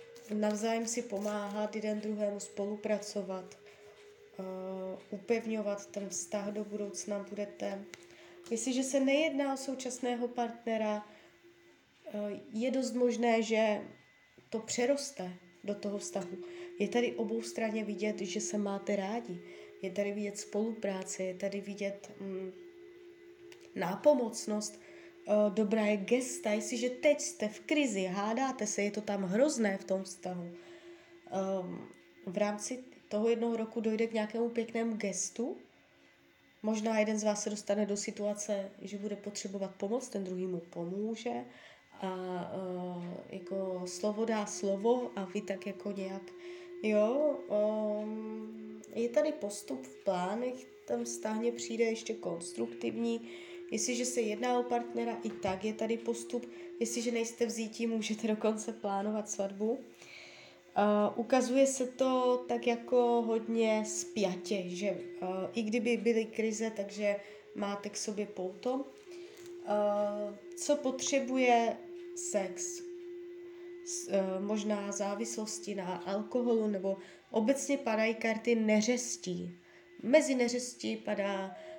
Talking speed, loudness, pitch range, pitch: 120 wpm, -34 LUFS, 195-240 Hz, 210 Hz